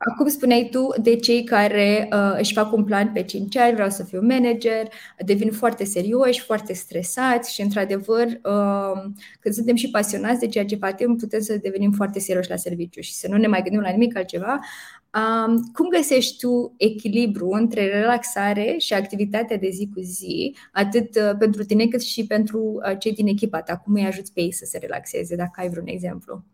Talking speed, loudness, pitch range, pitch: 190 wpm, -21 LUFS, 200-235 Hz, 215 Hz